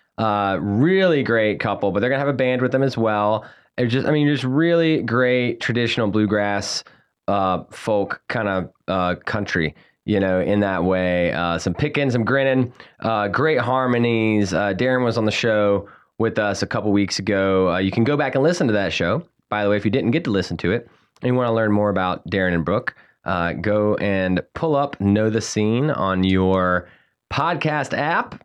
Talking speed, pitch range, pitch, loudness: 205 wpm, 100-125 Hz, 105 Hz, -20 LUFS